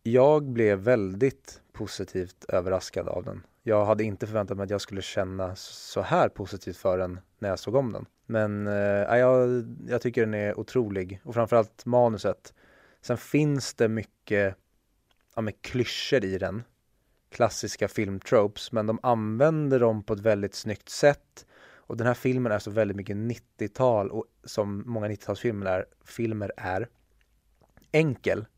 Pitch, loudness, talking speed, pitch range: 110 Hz, -27 LUFS, 155 wpm, 100-120 Hz